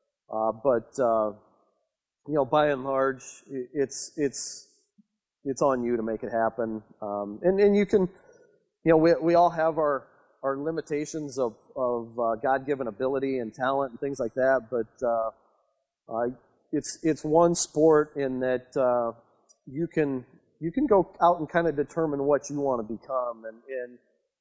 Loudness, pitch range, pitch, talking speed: -27 LUFS, 120-160 Hz, 135 Hz, 170 wpm